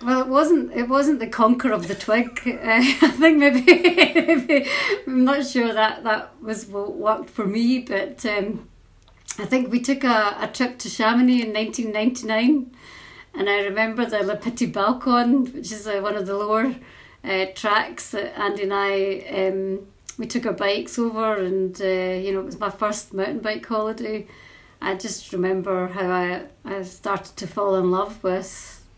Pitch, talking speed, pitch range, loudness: 215 Hz, 180 wpm, 200-250 Hz, -21 LUFS